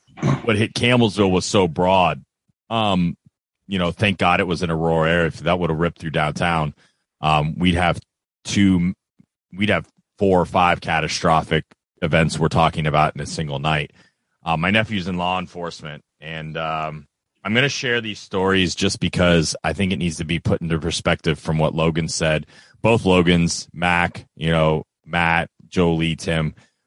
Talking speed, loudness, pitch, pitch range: 175 wpm, -20 LUFS, 85 Hz, 80-95 Hz